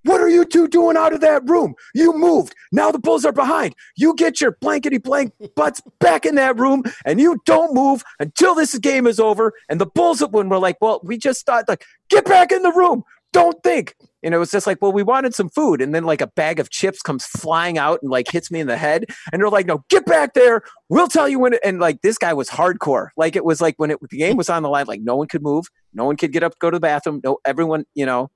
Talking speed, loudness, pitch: 270 wpm, -17 LUFS, 210 Hz